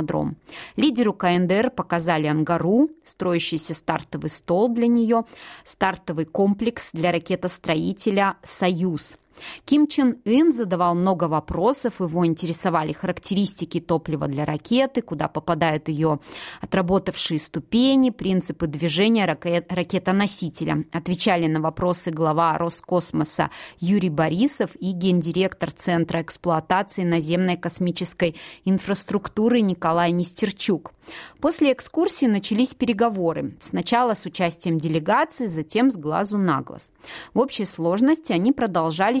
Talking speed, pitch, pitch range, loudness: 105 wpm, 180 Hz, 165-220 Hz, -22 LUFS